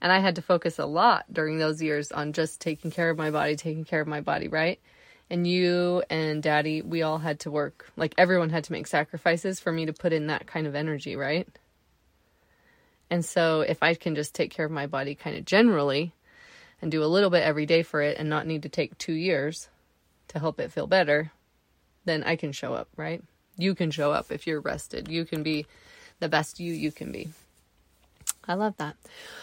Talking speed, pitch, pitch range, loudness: 220 wpm, 160 Hz, 150-170 Hz, -27 LUFS